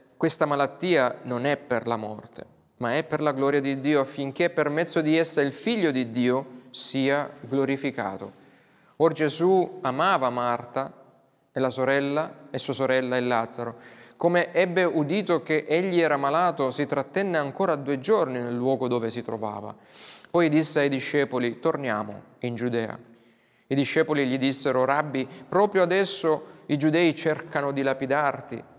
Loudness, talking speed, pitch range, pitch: -25 LUFS, 150 wpm, 125-155 Hz, 140 Hz